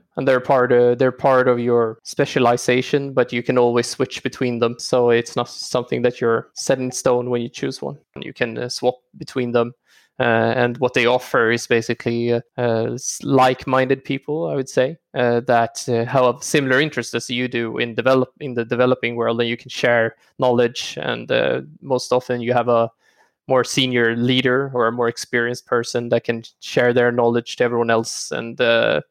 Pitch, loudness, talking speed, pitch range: 125 Hz, -19 LUFS, 190 wpm, 120-130 Hz